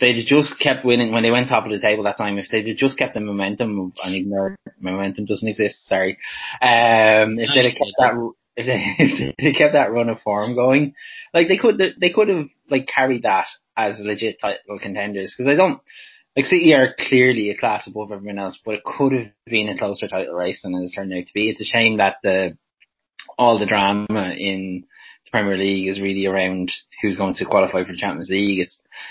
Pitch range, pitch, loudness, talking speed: 95-125 Hz, 105 Hz, -19 LUFS, 220 wpm